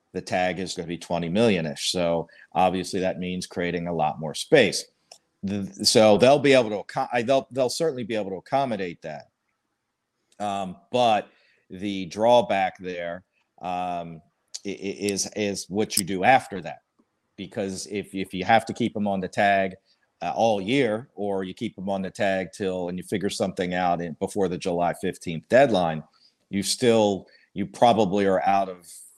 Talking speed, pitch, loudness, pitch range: 175 wpm, 95 Hz, -24 LUFS, 90-105 Hz